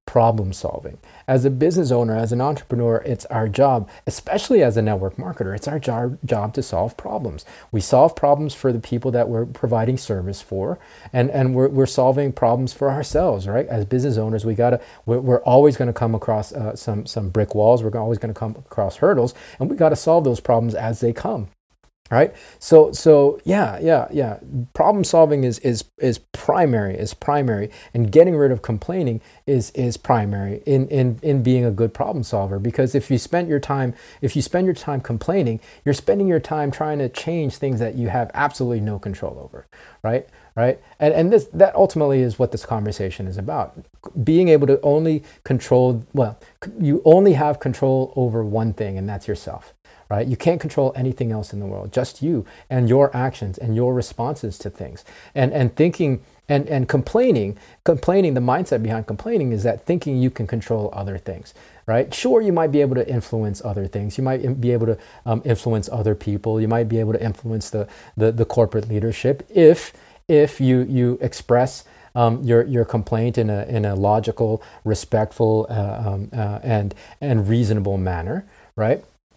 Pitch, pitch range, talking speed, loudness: 120 Hz, 110-140 Hz, 190 wpm, -20 LUFS